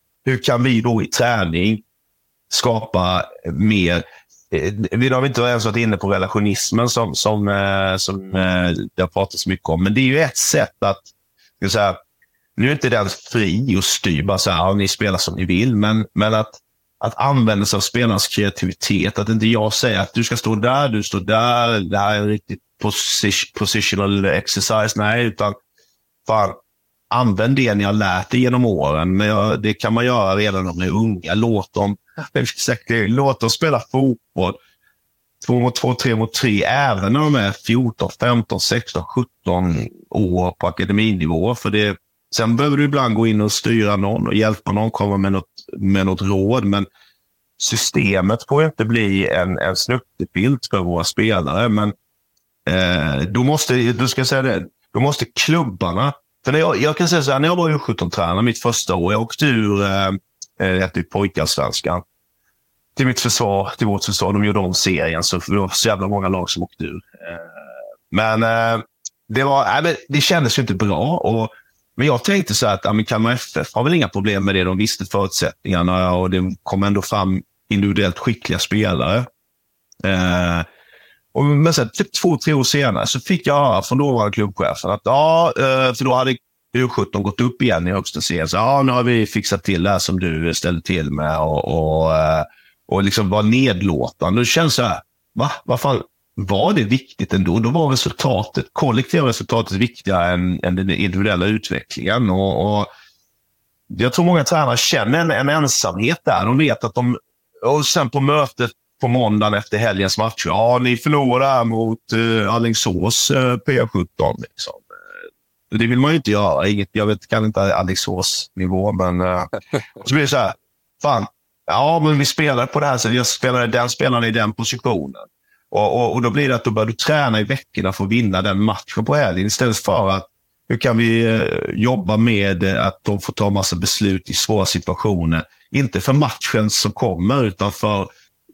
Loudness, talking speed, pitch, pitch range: -18 LUFS, 180 wpm, 110 Hz, 95-125 Hz